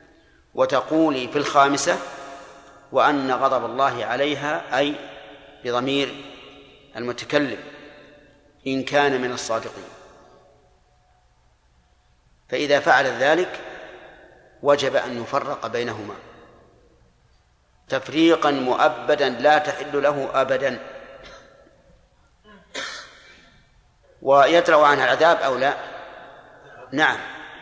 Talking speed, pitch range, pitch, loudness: 70 wpm, 125-145 Hz, 140 Hz, -21 LUFS